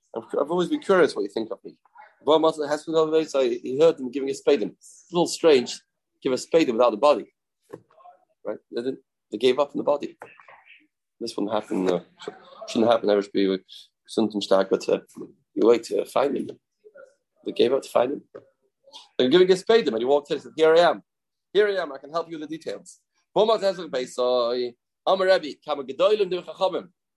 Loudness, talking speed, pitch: -23 LUFS, 205 wpm, 175 Hz